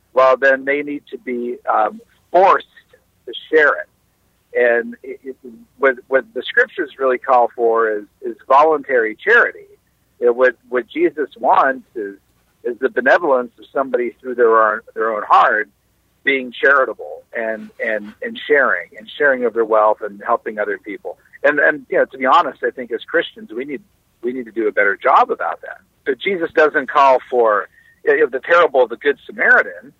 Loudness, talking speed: -16 LUFS, 185 wpm